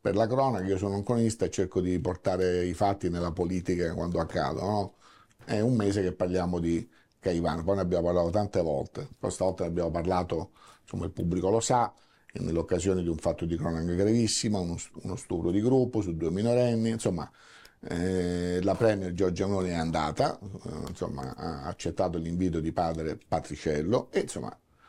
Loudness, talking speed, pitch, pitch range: -29 LUFS, 180 wpm, 90 Hz, 85-100 Hz